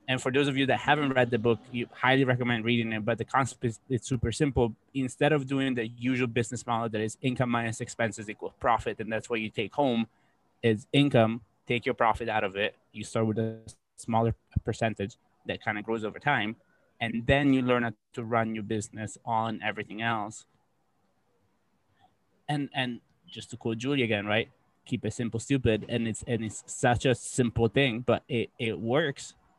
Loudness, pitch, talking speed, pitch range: -29 LUFS, 115 Hz, 200 wpm, 110-130 Hz